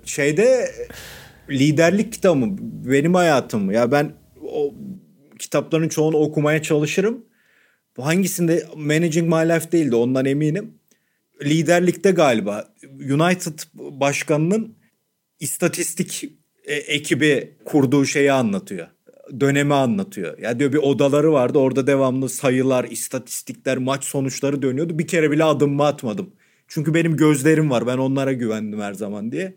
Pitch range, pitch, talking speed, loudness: 140-175 Hz, 155 Hz, 125 wpm, -19 LUFS